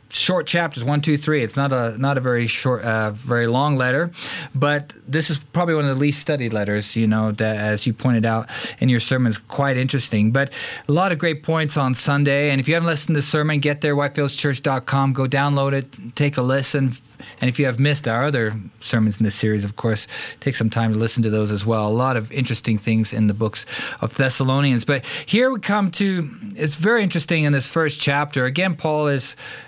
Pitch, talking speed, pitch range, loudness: 135 Hz, 220 wpm, 115-150 Hz, -19 LUFS